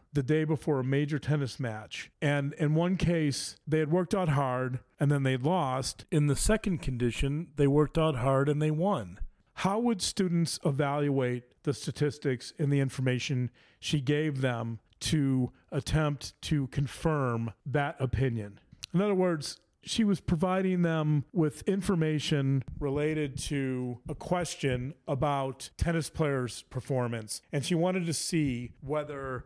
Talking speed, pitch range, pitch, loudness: 145 wpm, 130-160 Hz, 145 Hz, -30 LUFS